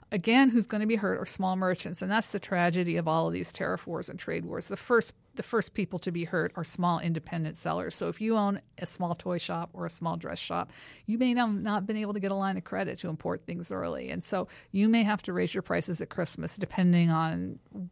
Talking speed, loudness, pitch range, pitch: 255 wpm, -30 LUFS, 170-210 Hz, 185 Hz